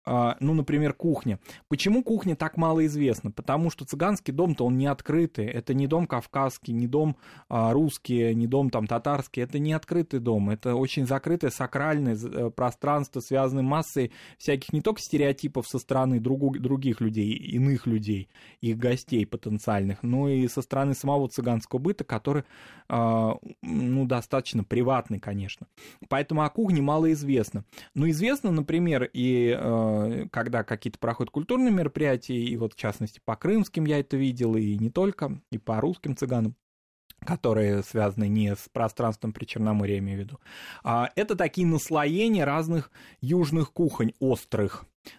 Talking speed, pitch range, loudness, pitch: 150 wpm, 115-150 Hz, -27 LUFS, 130 Hz